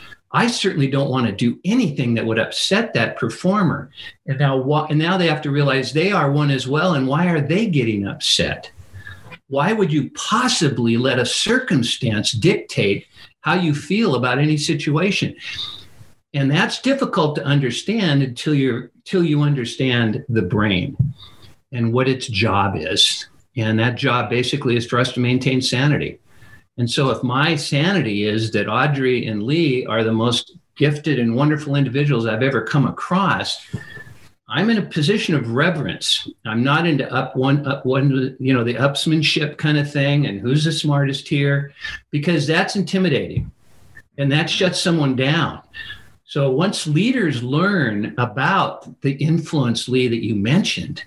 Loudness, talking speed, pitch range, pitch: -19 LUFS, 160 wpm, 125-160 Hz, 140 Hz